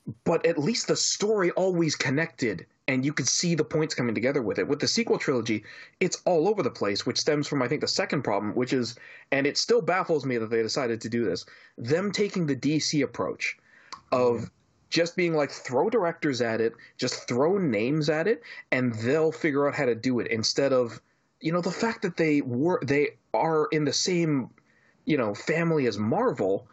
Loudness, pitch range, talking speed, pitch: -26 LUFS, 125-165 Hz, 205 wpm, 145 Hz